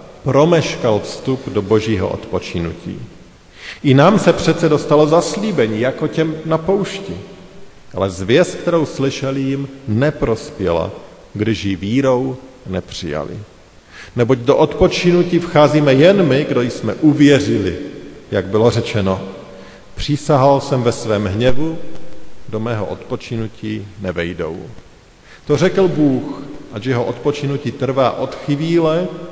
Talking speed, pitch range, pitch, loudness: 115 wpm, 110-155 Hz, 135 Hz, -16 LUFS